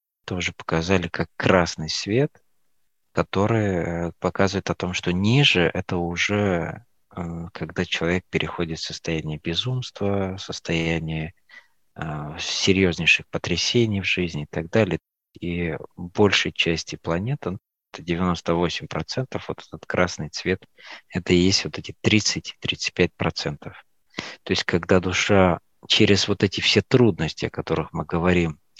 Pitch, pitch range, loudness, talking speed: 90 Hz, 85-100 Hz, -23 LUFS, 115 wpm